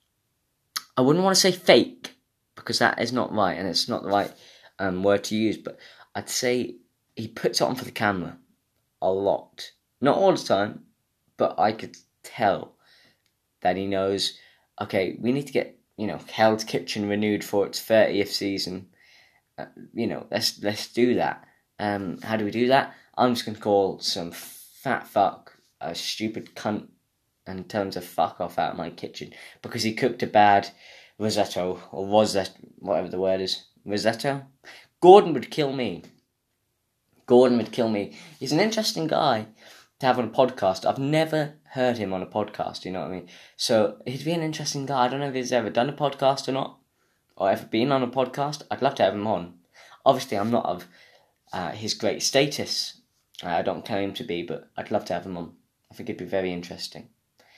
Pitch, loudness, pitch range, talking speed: 110 Hz, -25 LUFS, 100-130 Hz, 200 wpm